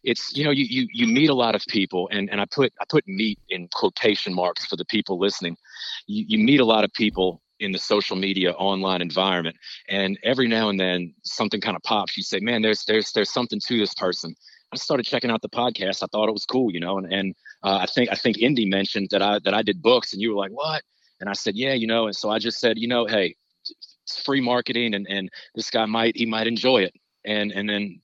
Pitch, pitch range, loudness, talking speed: 105 Hz, 95-115 Hz, -23 LUFS, 255 wpm